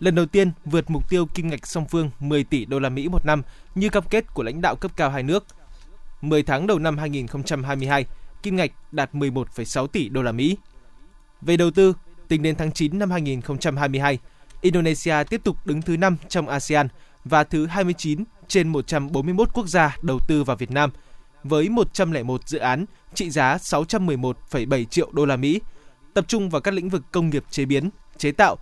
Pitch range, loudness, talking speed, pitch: 140-175 Hz, -23 LUFS, 195 wpm, 155 Hz